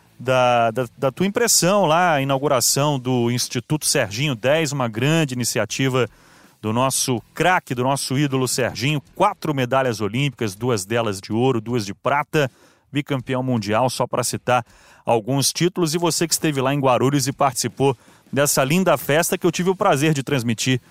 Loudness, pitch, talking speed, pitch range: -20 LUFS, 135 Hz, 165 wpm, 125-150 Hz